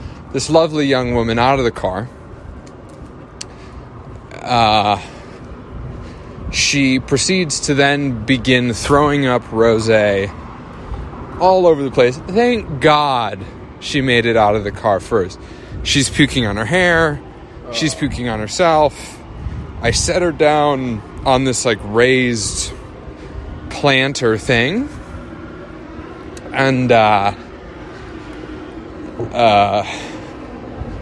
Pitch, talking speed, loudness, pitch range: 125 Hz, 105 wpm, -15 LUFS, 110-145 Hz